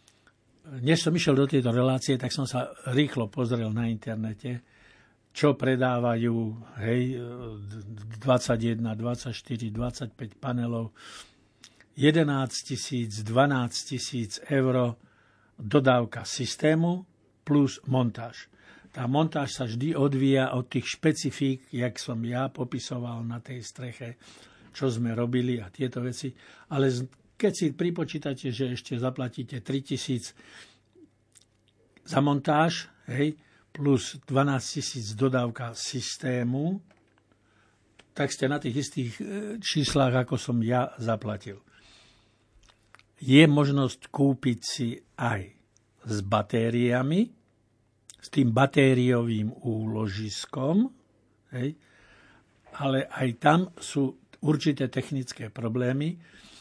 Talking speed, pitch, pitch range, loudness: 100 wpm, 125 Hz, 115-140 Hz, -27 LUFS